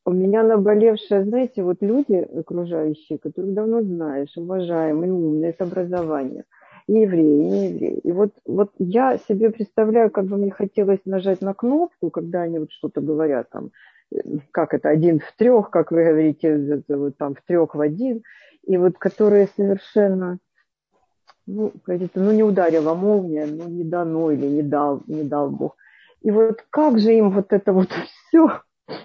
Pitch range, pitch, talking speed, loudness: 160-210 Hz, 185 Hz, 160 wpm, -20 LUFS